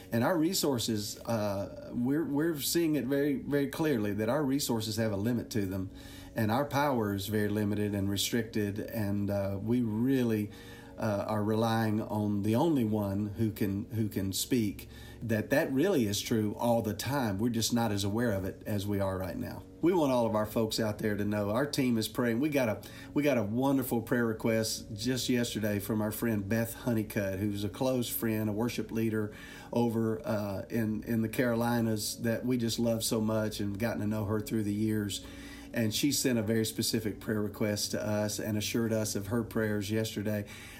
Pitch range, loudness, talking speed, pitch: 105-120 Hz, -31 LUFS, 200 wpm, 110 Hz